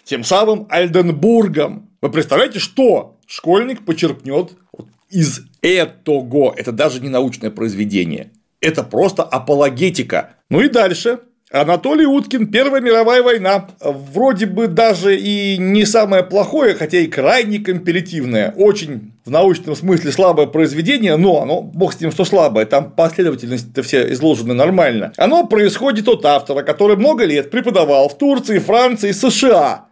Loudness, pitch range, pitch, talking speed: -14 LUFS, 145-225 Hz, 185 Hz, 135 wpm